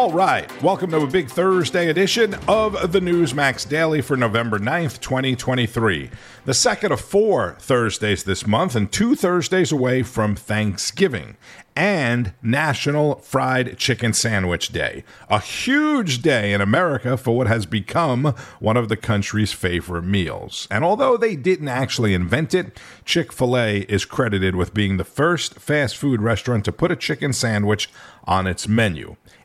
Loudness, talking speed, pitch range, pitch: -20 LUFS, 155 wpm, 105-155 Hz, 125 Hz